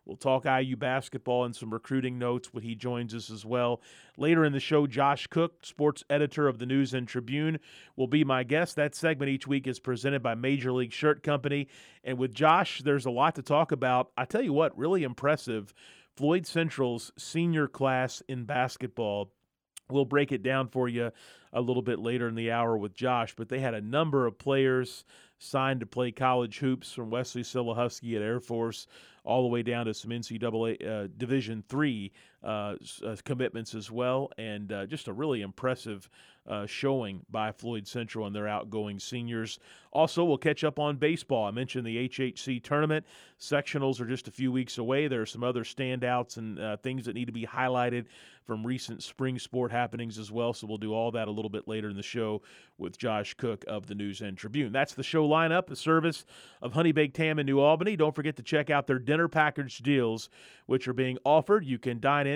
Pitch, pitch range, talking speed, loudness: 125 Hz, 115-140 Hz, 205 wpm, -30 LUFS